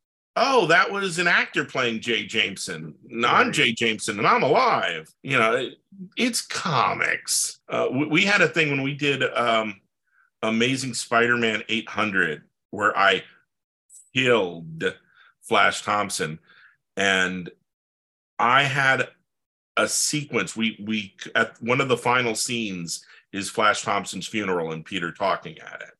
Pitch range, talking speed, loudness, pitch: 100-130 Hz, 135 wpm, -22 LUFS, 115 Hz